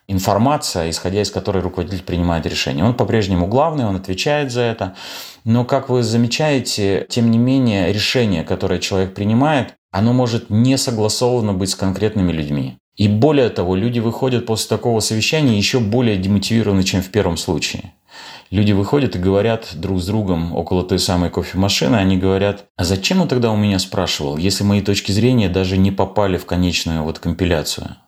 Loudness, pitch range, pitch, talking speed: -17 LUFS, 95-115 Hz, 100 Hz, 170 wpm